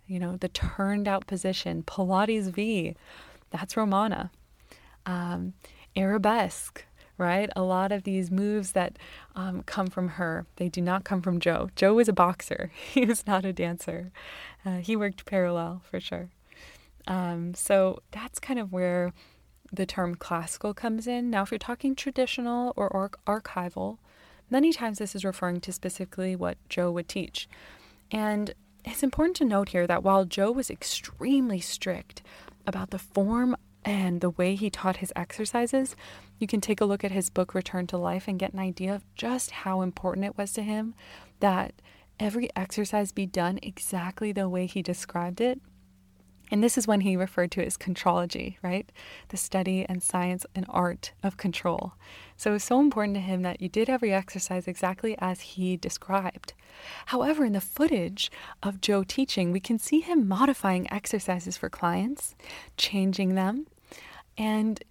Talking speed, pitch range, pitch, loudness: 170 wpm, 180-215 Hz, 195 Hz, -29 LUFS